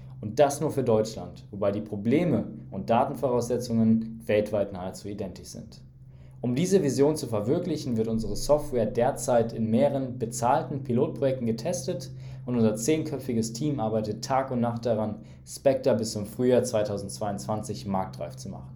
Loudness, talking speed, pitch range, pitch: -27 LUFS, 145 wpm, 105-130 Hz, 115 Hz